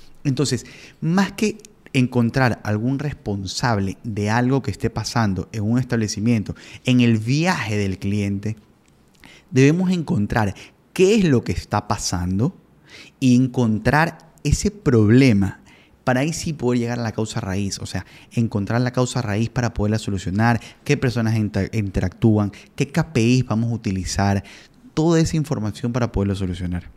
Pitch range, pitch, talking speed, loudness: 105-130 Hz, 115 Hz, 140 wpm, -21 LUFS